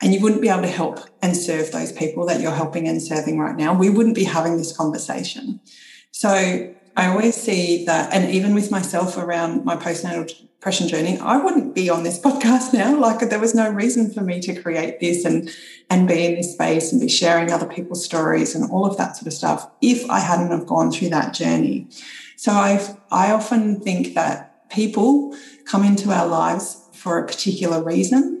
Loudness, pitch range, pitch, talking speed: -19 LUFS, 170-215 Hz, 185 Hz, 205 wpm